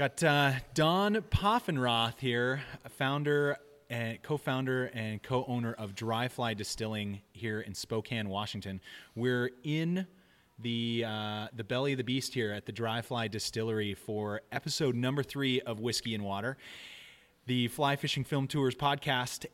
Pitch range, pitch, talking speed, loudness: 110-140 Hz, 125 Hz, 145 wpm, -33 LUFS